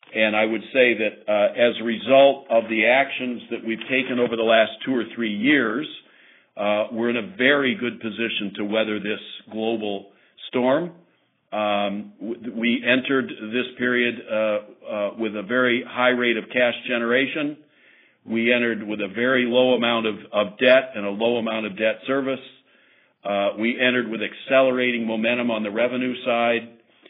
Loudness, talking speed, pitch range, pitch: -22 LUFS, 170 wpm, 110-125 Hz, 115 Hz